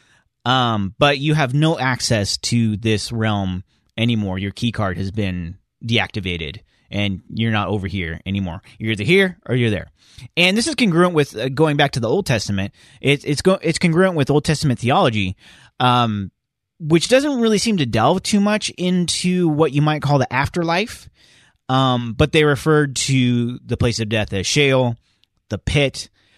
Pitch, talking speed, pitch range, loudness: 125 Hz, 175 wpm, 105-155 Hz, -18 LUFS